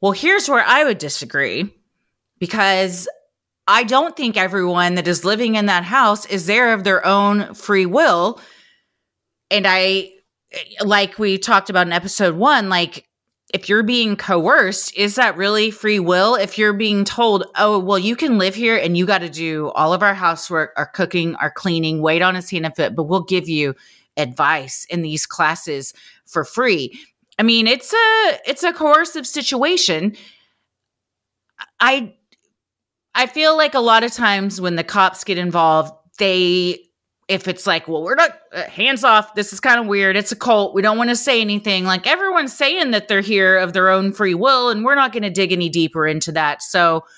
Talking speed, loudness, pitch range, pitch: 190 wpm, -16 LUFS, 180-225 Hz, 195 Hz